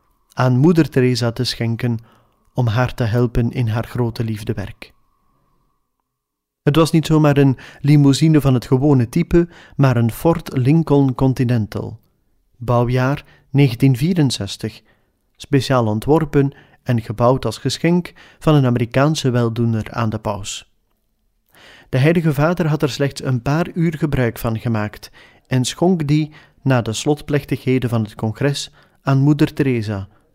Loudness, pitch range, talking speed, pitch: -18 LUFS, 115-150 Hz, 130 wpm, 130 Hz